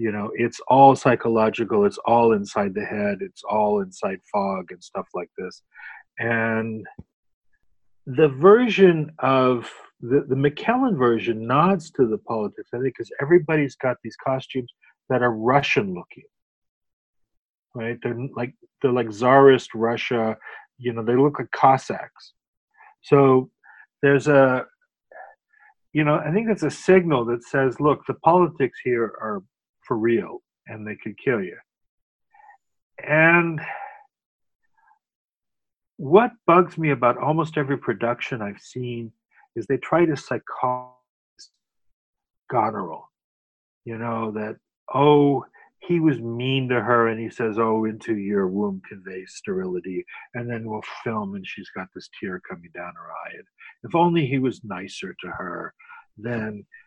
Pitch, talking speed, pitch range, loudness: 130 Hz, 140 wpm, 115-160 Hz, -21 LUFS